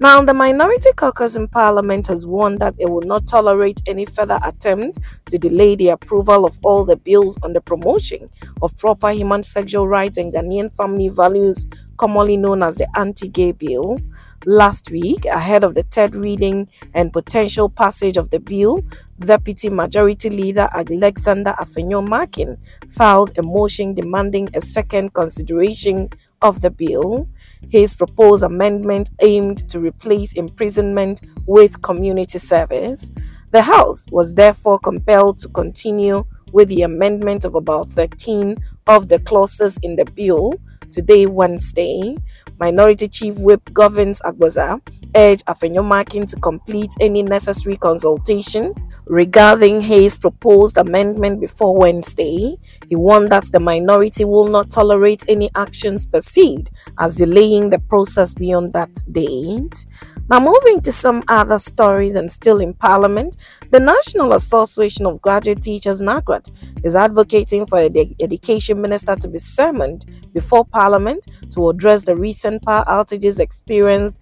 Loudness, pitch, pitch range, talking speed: -14 LUFS, 205 Hz, 190-210 Hz, 140 wpm